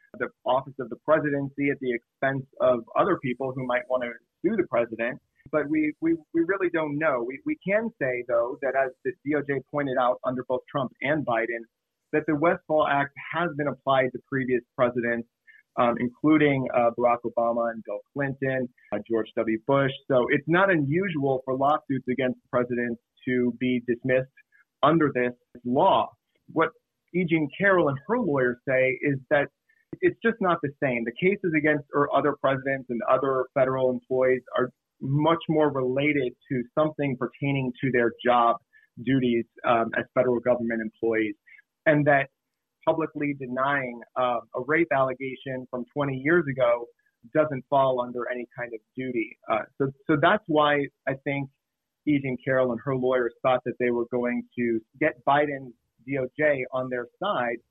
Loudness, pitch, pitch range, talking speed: -26 LUFS, 130 Hz, 125-150 Hz, 165 wpm